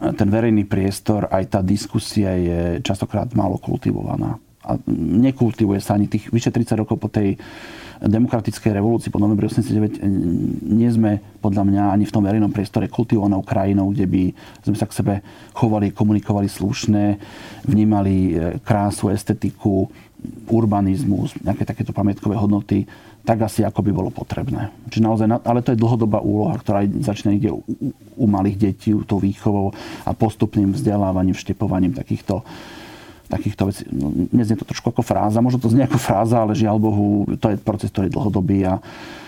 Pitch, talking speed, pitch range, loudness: 105 Hz, 155 wpm, 100-115 Hz, -20 LUFS